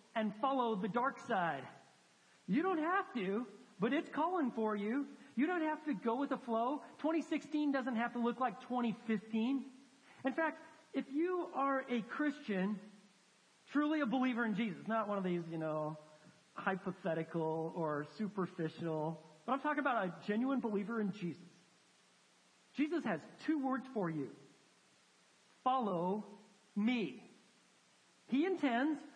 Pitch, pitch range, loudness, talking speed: 235 Hz, 195-275 Hz, -38 LUFS, 140 wpm